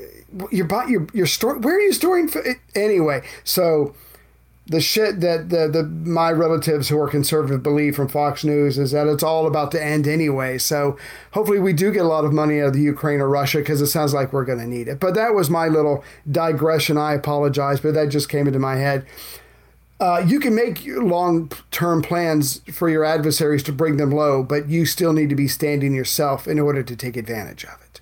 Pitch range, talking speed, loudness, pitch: 145-165 Hz, 220 wpm, -19 LUFS, 150 Hz